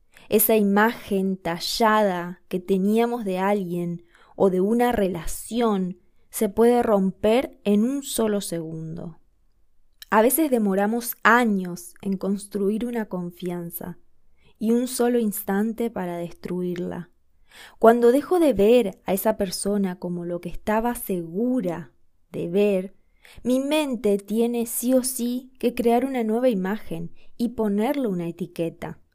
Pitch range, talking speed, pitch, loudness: 180-235 Hz, 125 wpm, 205 Hz, -23 LUFS